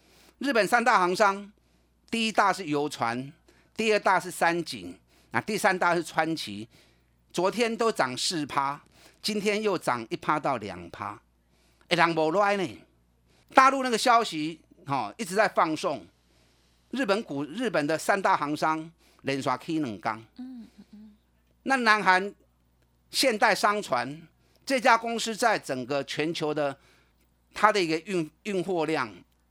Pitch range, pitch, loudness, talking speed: 130-210 Hz, 165 Hz, -26 LUFS, 190 characters per minute